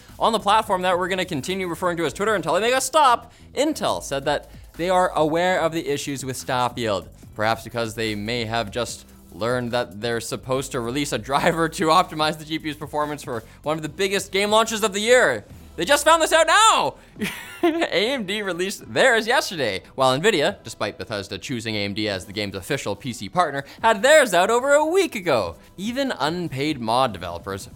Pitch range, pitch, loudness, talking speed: 120-200 Hz, 155 Hz, -21 LUFS, 195 wpm